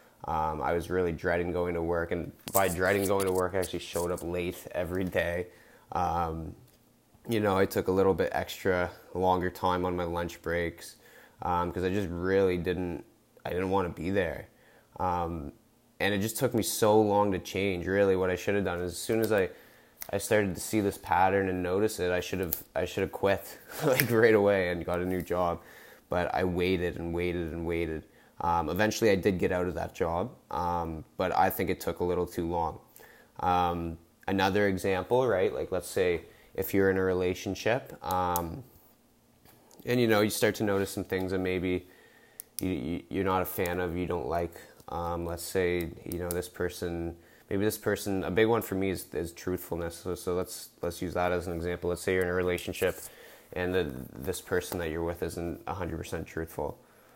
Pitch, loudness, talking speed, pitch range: 90 Hz, -30 LUFS, 205 wpm, 85-95 Hz